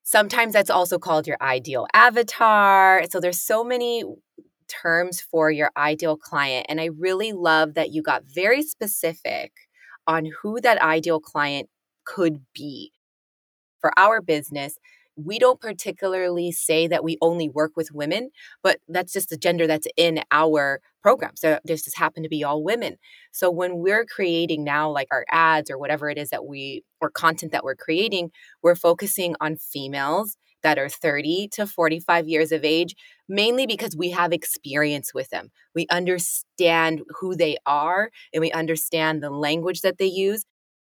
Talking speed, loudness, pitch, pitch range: 165 wpm, -22 LUFS, 165 Hz, 155-190 Hz